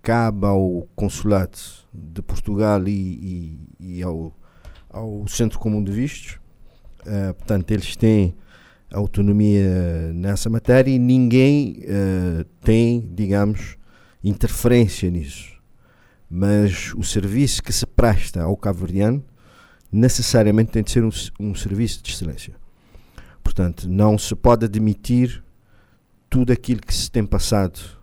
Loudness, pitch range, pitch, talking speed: -20 LUFS, 95-115 Hz, 105 Hz, 120 wpm